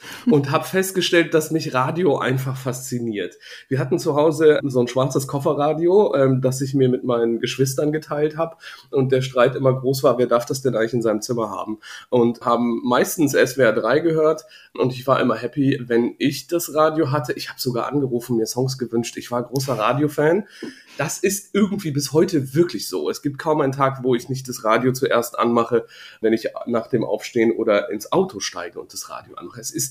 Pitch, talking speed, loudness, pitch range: 135 Hz, 205 wpm, -20 LUFS, 120-155 Hz